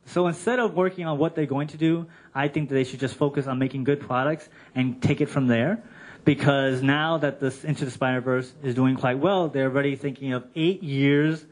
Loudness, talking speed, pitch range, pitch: -25 LUFS, 225 wpm, 130-155 Hz, 145 Hz